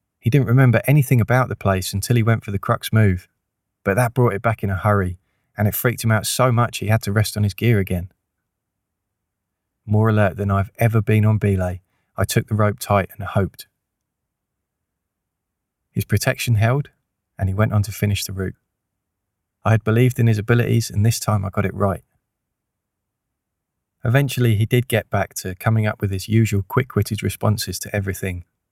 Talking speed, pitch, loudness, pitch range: 190 wpm, 105 Hz, -20 LUFS, 95-115 Hz